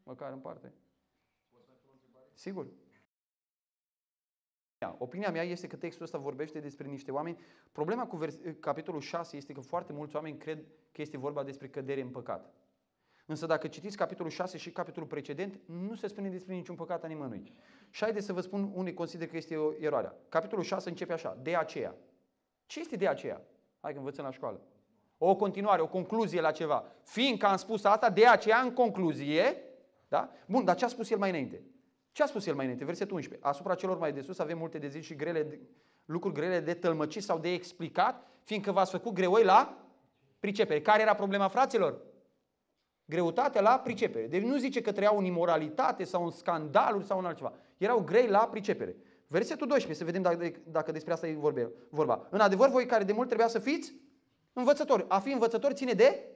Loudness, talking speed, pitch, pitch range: -31 LUFS, 190 wpm, 180 Hz, 155-215 Hz